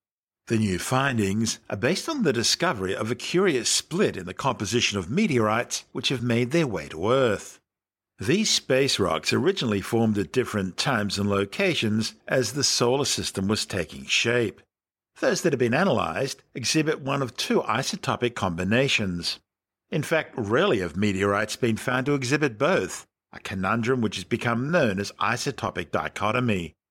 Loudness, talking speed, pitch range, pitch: -24 LUFS, 160 wpm, 100-130 Hz, 110 Hz